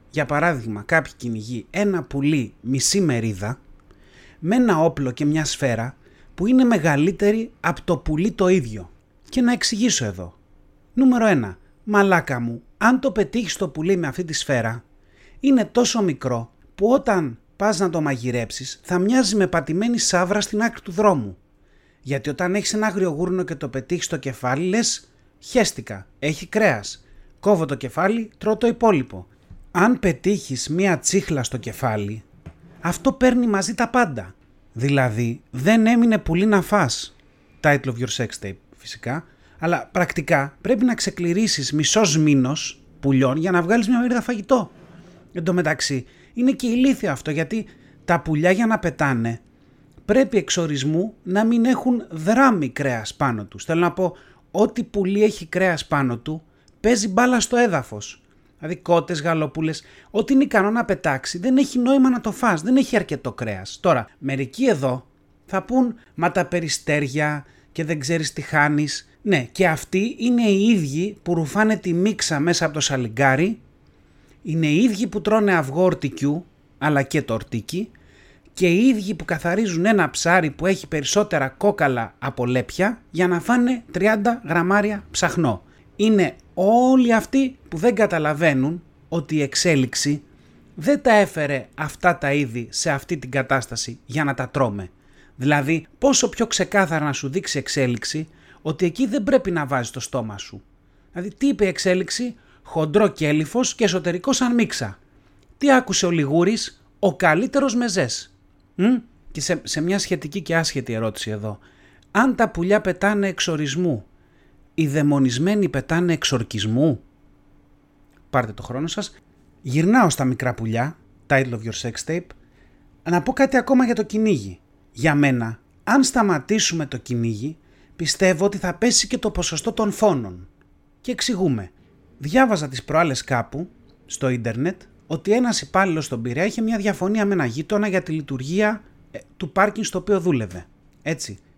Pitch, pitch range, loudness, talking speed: 170 Hz, 135-210 Hz, -21 LUFS, 155 wpm